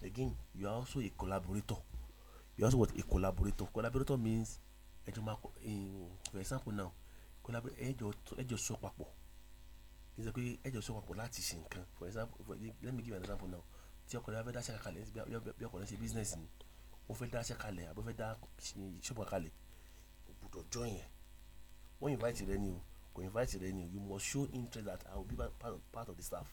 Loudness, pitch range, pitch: -43 LUFS, 90-115 Hz, 100 Hz